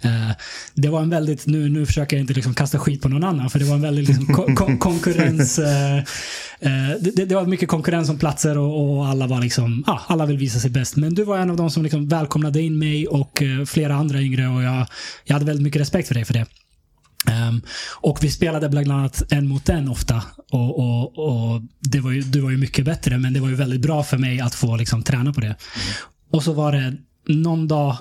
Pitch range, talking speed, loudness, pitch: 130-155 Hz, 245 wpm, -20 LUFS, 145 Hz